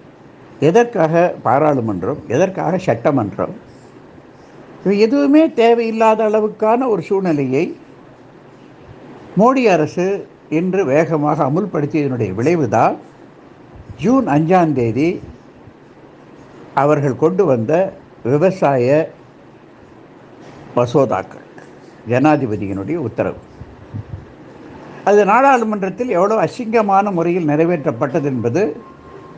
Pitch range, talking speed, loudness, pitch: 145-215 Hz, 65 wpm, -16 LUFS, 170 Hz